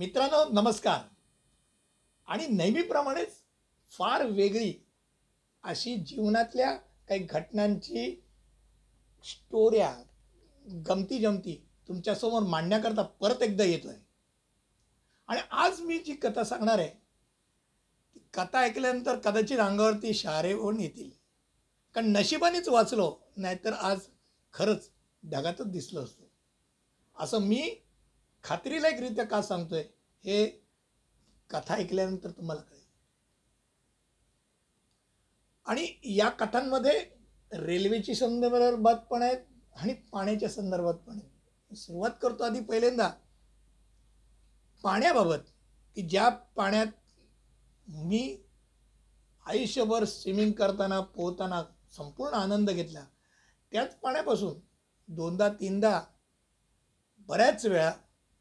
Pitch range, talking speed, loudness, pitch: 190-235 Hz, 90 wpm, -30 LUFS, 210 Hz